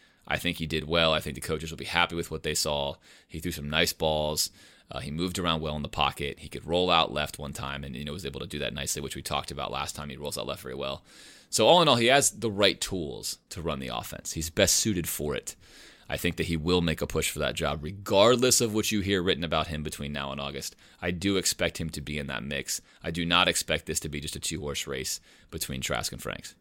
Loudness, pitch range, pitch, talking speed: -28 LUFS, 75-85 Hz, 80 Hz, 275 wpm